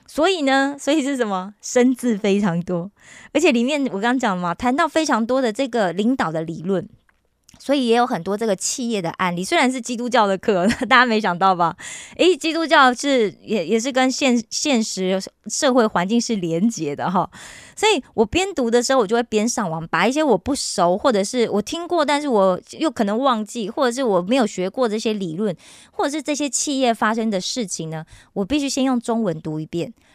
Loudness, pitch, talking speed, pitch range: -20 LUFS, 235 Hz, 305 characters per minute, 195-265 Hz